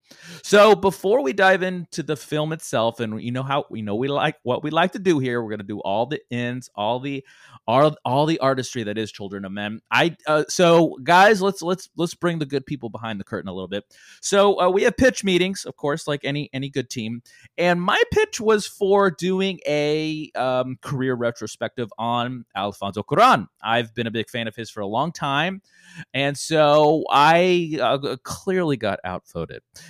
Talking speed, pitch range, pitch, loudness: 205 wpm, 120-175 Hz, 145 Hz, -21 LUFS